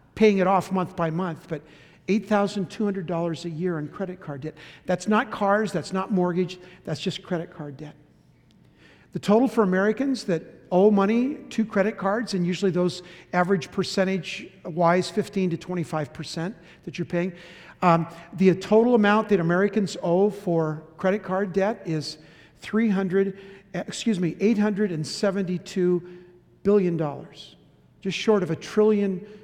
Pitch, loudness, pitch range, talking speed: 185 Hz, -24 LUFS, 170-200 Hz, 160 wpm